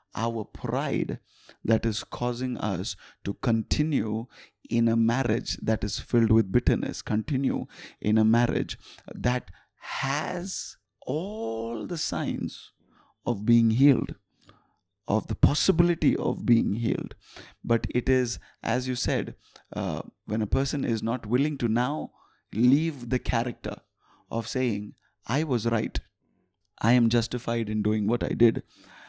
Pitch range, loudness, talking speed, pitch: 110-125 Hz, -27 LUFS, 135 wpm, 115 Hz